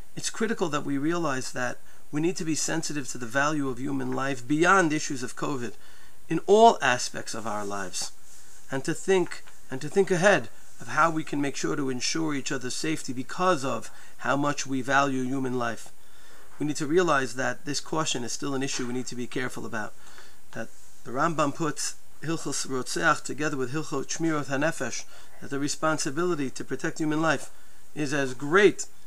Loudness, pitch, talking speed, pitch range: -27 LUFS, 140 Hz, 190 wpm, 130-160 Hz